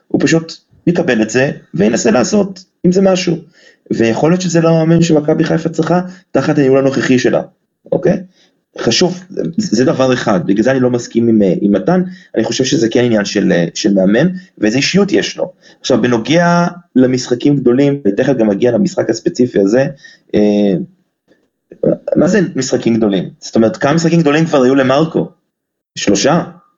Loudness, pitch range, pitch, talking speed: -13 LUFS, 125-175 Hz, 150 Hz, 160 wpm